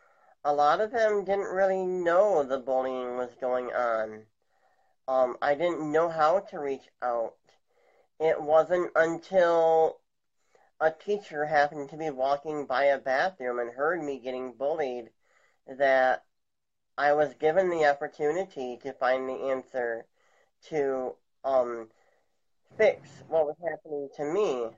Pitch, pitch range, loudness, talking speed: 145 Hz, 130-160 Hz, -28 LUFS, 135 wpm